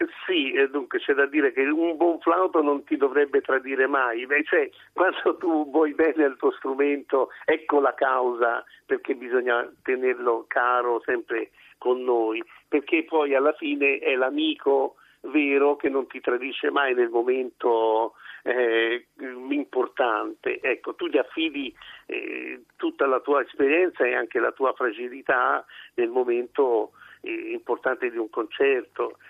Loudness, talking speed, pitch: -24 LUFS, 145 wpm, 285 Hz